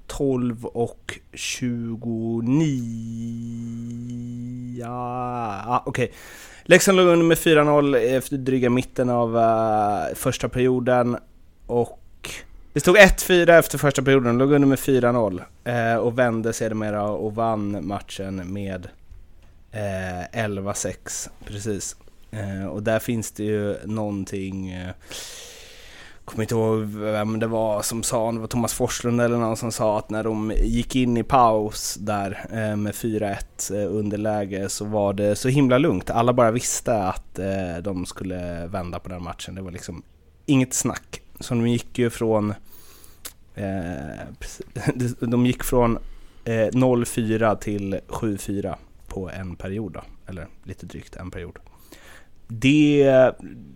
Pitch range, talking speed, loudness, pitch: 100-125 Hz, 125 wpm, -22 LUFS, 110 Hz